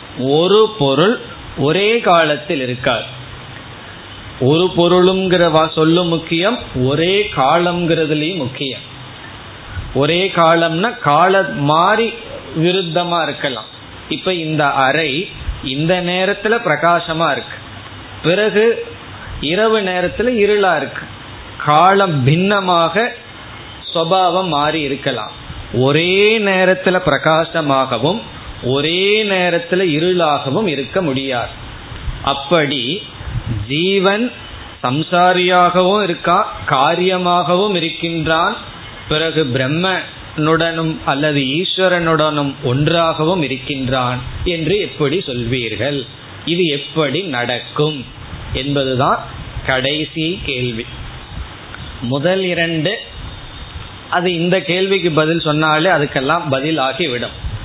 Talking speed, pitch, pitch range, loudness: 75 wpm, 155 Hz, 130-180 Hz, -15 LUFS